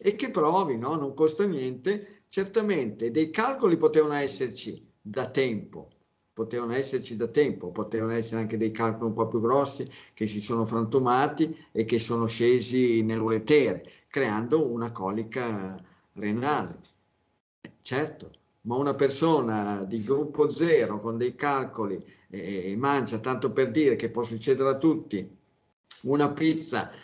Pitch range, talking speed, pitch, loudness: 110-145 Hz, 140 wpm, 120 Hz, -27 LUFS